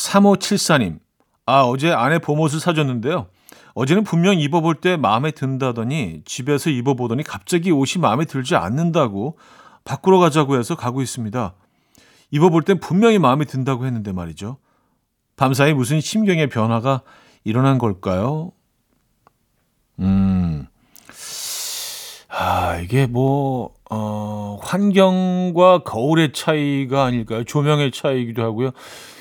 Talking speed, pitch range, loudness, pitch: 270 characters per minute, 120-165 Hz, -19 LUFS, 135 Hz